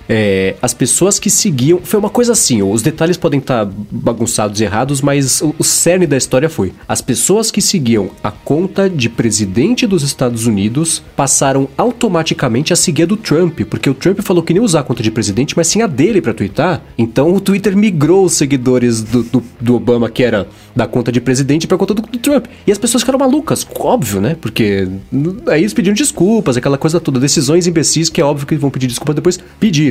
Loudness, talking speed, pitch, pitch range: -13 LUFS, 215 wpm, 150 Hz, 120-185 Hz